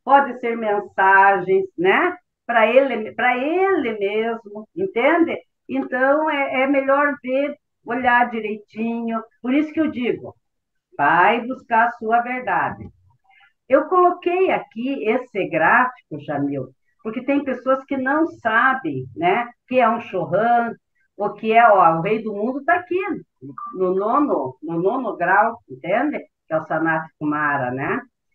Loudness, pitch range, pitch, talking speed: -19 LUFS, 205-280 Hz, 240 Hz, 140 wpm